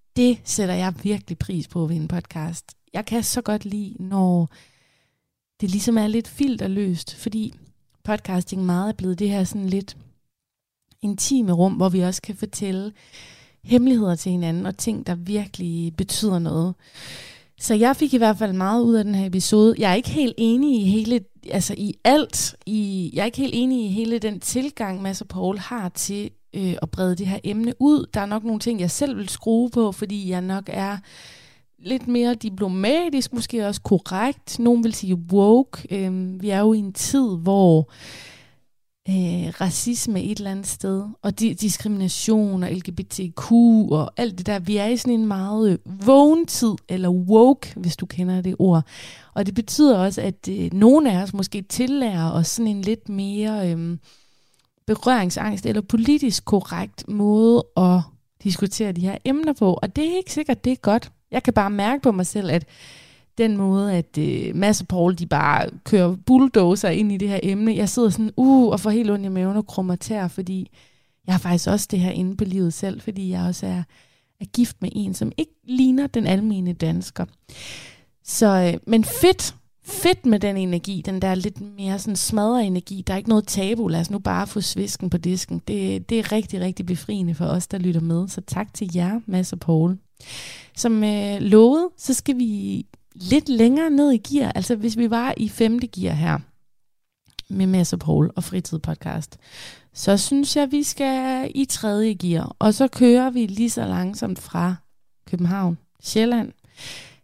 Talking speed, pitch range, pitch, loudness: 190 wpm, 180-225 Hz, 200 Hz, -21 LUFS